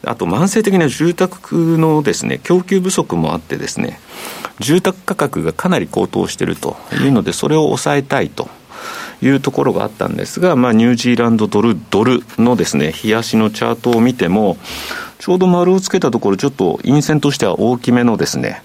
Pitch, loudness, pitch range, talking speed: 150 Hz, -15 LUFS, 120-180 Hz, 385 characters per minute